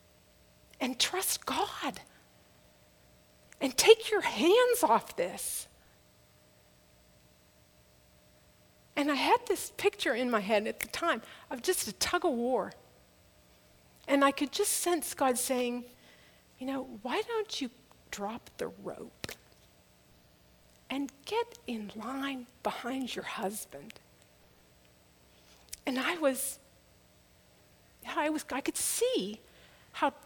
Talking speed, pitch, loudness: 115 wpm, 245 Hz, -31 LUFS